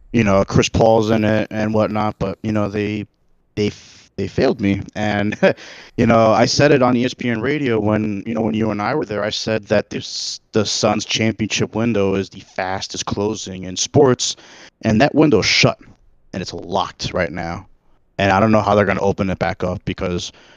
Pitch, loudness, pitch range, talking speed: 105 Hz, -18 LUFS, 95-110 Hz, 205 wpm